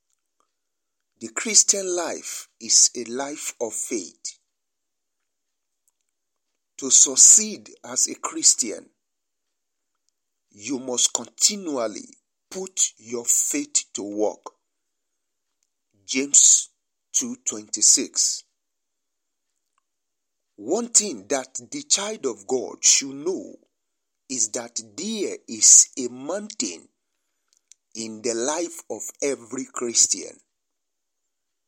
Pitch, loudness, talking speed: 205 Hz, -19 LUFS, 85 wpm